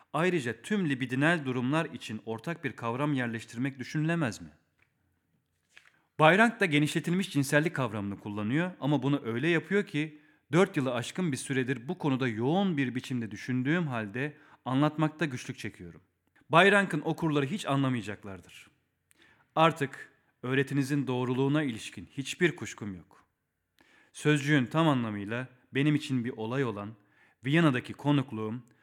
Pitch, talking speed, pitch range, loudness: 140 Hz, 120 wpm, 120-155 Hz, -29 LUFS